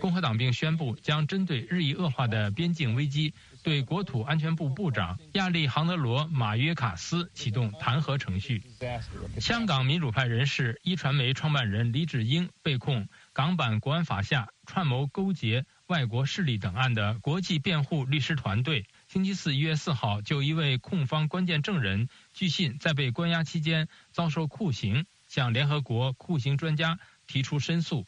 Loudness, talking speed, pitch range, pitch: -29 LUFS, 265 characters per minute, 125-165 Hz, 145 Hz